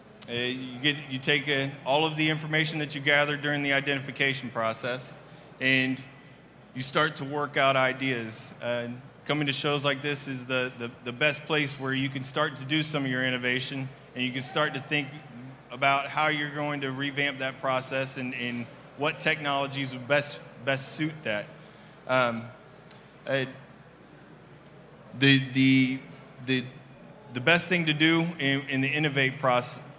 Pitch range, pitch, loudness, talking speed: 130-145 Hz, 135 Hz, -27 LUFS, 170 wpm